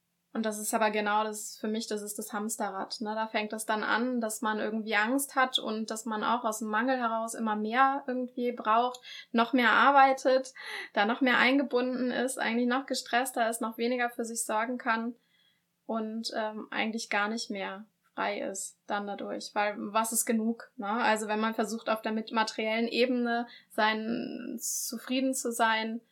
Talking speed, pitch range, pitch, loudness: 185 wpm, 215-245 Hz, 225 Hz, -30 LUFS